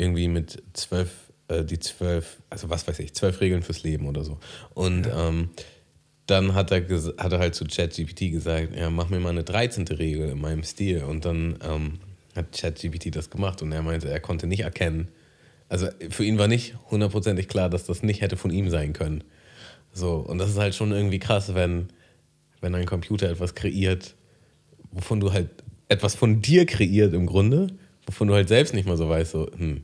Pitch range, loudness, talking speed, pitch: 80-100 Hz, -25 LUFS, 200 wpm, 90 Hz